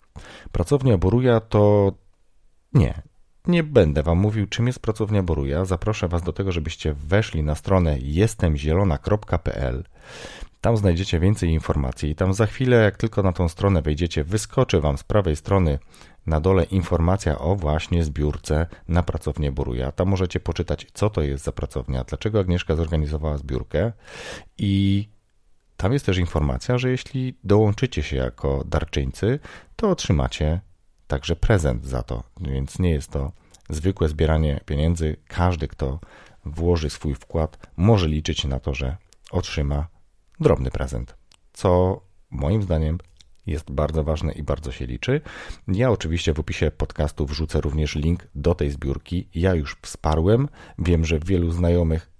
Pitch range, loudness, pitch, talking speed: 75-95 Hz, -23 LUFS, 85 Hz, 145 wpm